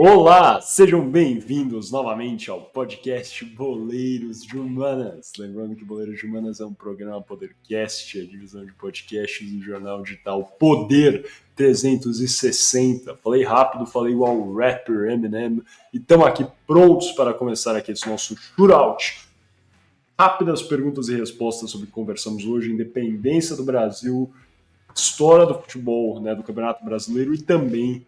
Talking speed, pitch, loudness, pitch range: 140 wpm, 115 Hz, -19 LUFS, 110-135 Hz